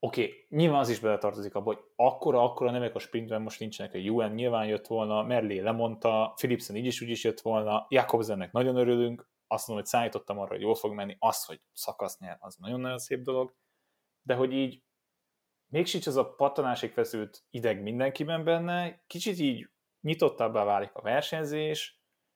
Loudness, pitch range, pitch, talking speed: -30 LUFS, 110-140 Hz, 125 Hz, 175 wpm